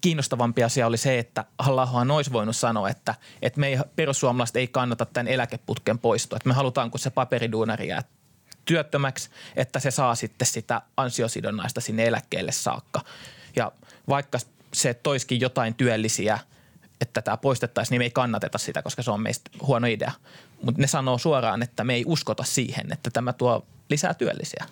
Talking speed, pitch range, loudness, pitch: 170 wpm, 115-135 Hz, -25 LUFS, 125 Hz